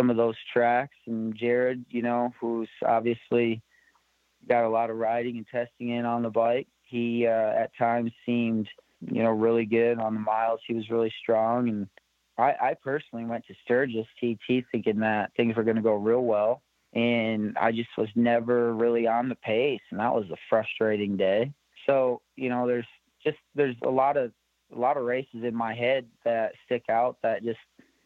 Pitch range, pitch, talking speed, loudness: 115-120 Hz, 115 Hz, 190 wpm, -27 LUFS